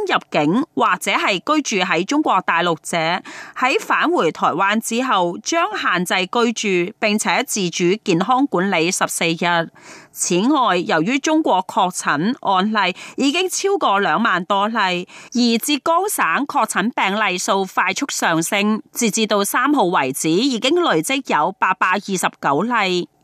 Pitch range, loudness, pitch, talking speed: 180-270 Hz, -18 LUFS, 215 Hz, 220 characters per minute